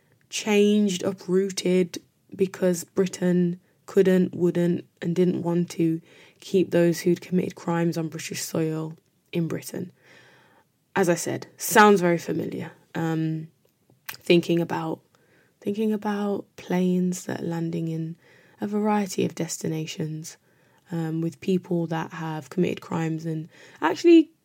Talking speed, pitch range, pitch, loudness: 120 wpm, 165-190 Hz, 175 Hz, -25 LUFS